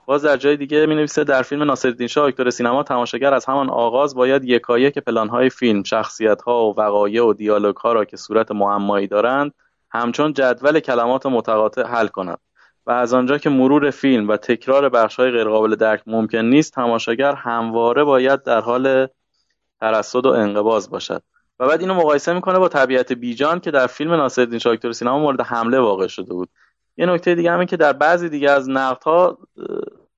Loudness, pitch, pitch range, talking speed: -17 LUFS, 130 Hz, 115-145 Hz, 180 wpm